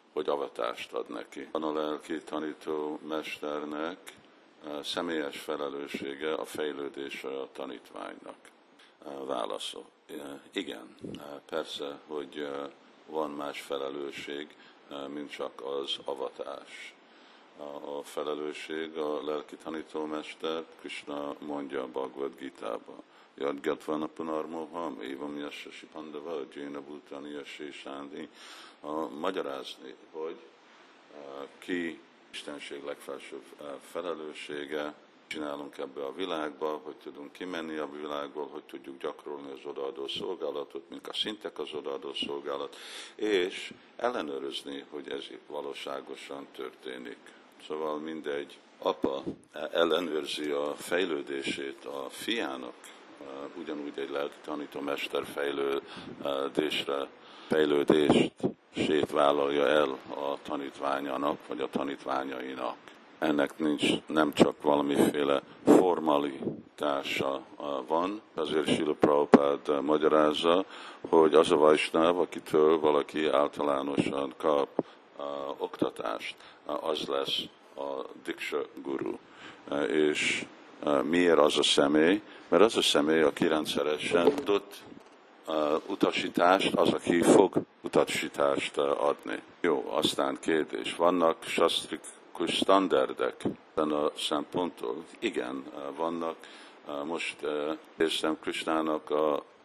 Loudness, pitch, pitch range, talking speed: -30 LUFS, 75 Hz, 70-80 Hz, 95 wpm